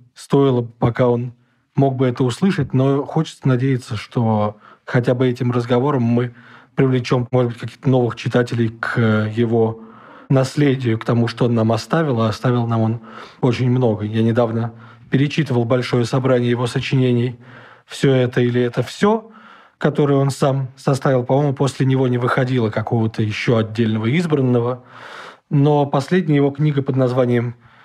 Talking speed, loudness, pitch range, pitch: 150 wpm, -18 LUFS, 120-135 Hz, 125 Hz